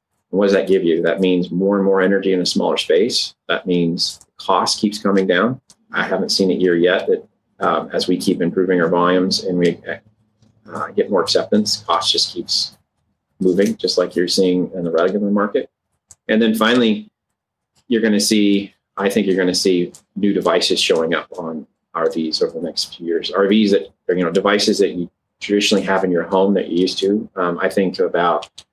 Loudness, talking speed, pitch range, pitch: -17 LUFS, 205 wpm, 90-105 Hz, 95 Hz